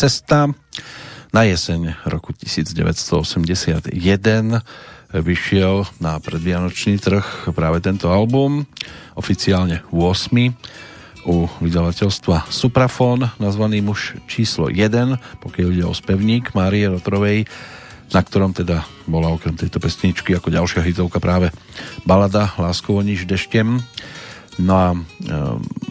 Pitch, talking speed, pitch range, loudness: 95 Hz, 105 wpm, 85-110 Hz, -18 LUFS